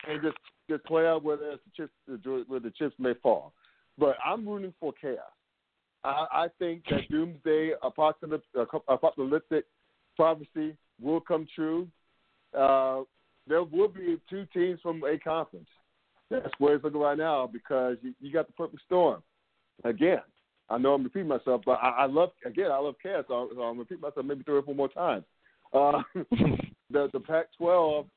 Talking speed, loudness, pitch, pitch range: 165 wpm, -29 LUFS, 155 Hz, 135-165 Hz